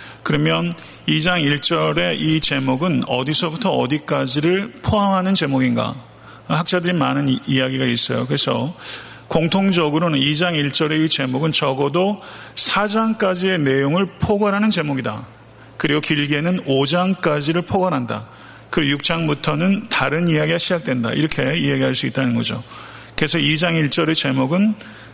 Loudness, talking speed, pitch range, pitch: -18 LUFS, 300 characters per minute, 135-175 Hz, 155 Hz